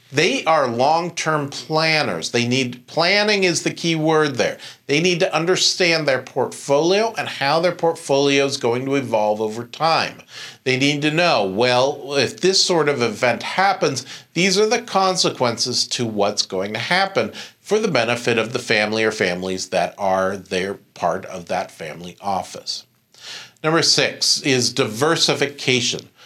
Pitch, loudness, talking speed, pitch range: 140 Hz, -19 LUFS, 155 wpm, 120-165 Hz